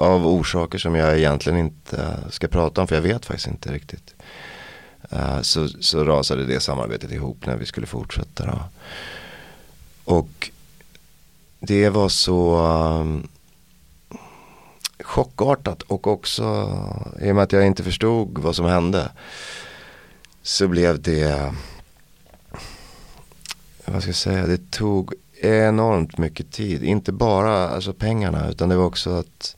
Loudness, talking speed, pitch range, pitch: -21 LUFS, 135 wpm, 80-100 Hz, 90 Hz